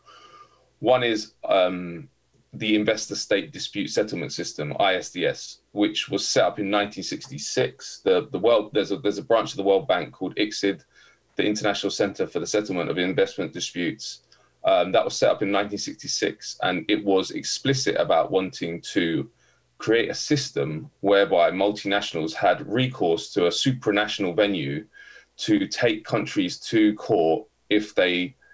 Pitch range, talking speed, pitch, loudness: 100-125 Hz, 145 wpm, 105 Hz, -24 LUFS